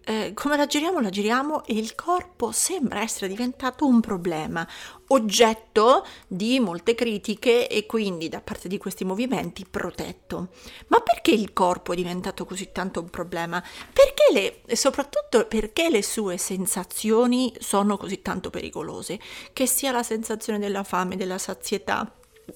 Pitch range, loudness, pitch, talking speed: 190-250 Hz, -24 LUFS, 215 Hz, 150 wpm